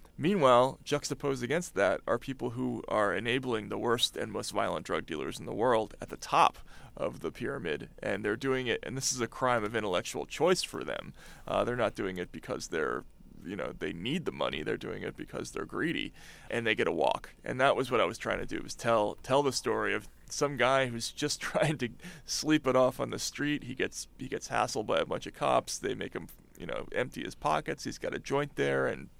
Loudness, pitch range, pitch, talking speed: -32 LUFS, 115-145 Hz, 130 Hz, 235 wpm